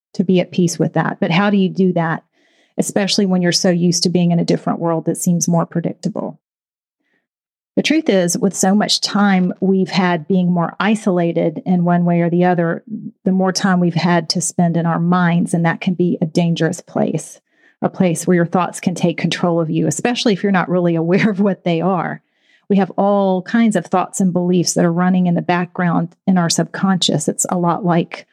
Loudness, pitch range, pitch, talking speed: -16 LUFS, 170-195 Hz, 180 Hz, 220 wpm